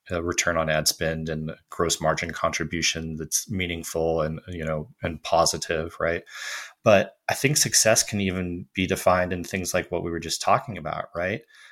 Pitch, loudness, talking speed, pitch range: 85 Hz, -24 LUFS, 175 wpm, 80-90 Hz